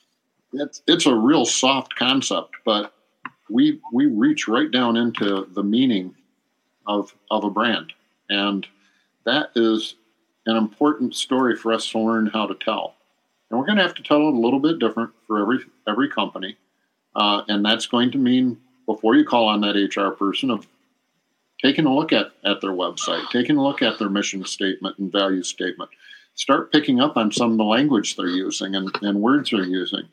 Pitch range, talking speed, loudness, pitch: 100-125 Hz, 185 wpm, -21 LUFS, 110 Hz